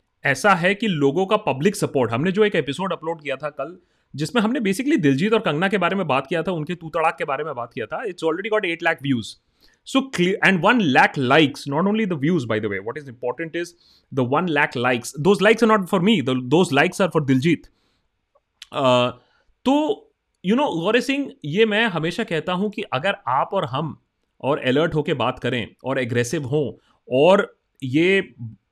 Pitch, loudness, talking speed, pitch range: 165 Hz, -21 LUFS, 200 wpm, 135-200 Hz